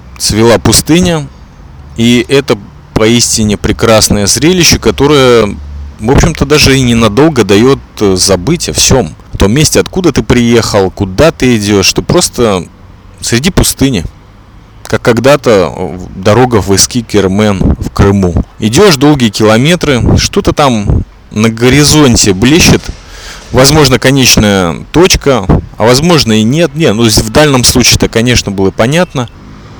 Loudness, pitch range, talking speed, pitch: -7 LUFS, 100-130 Hz, 125 wpm, 115 Hz